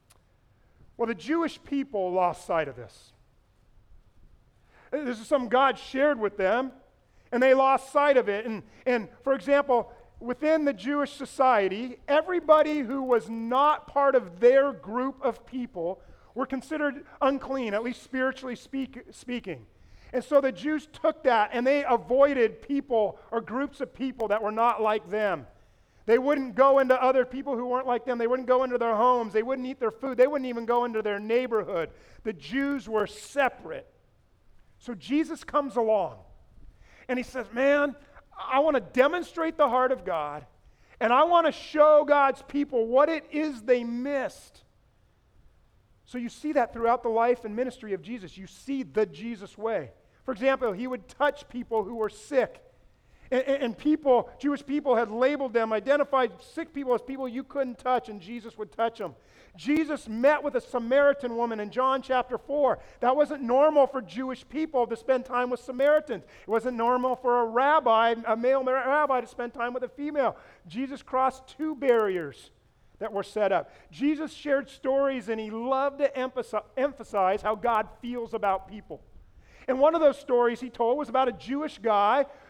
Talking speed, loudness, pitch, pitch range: 175 wpm, -26 LUFS, 250 Hz, 225-275 Hz